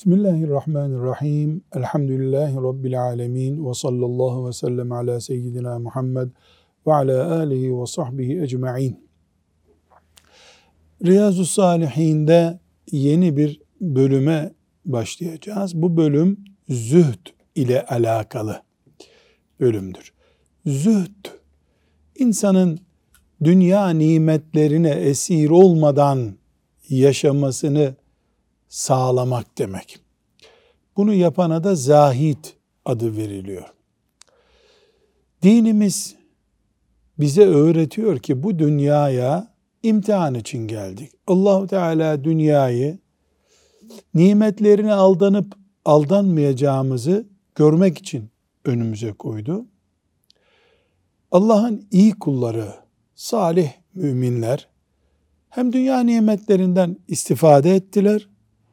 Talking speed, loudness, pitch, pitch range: 75 wpm, -18 LUFS, 150 Hz, 125-185 Hz